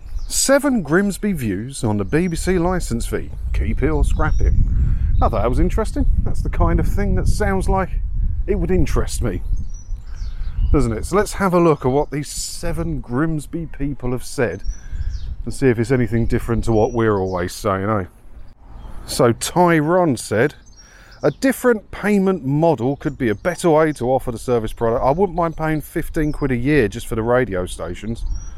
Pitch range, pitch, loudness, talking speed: 100-165 Hz, 125 Hz, -20 LUFS, 185 wpm